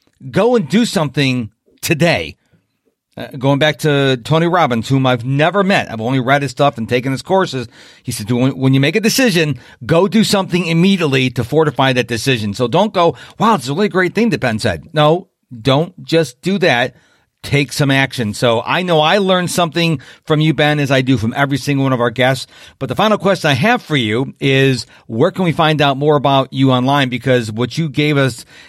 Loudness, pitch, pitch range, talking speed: -14 LUFS, 140 Hz, 130-170 Hz, 215 wpm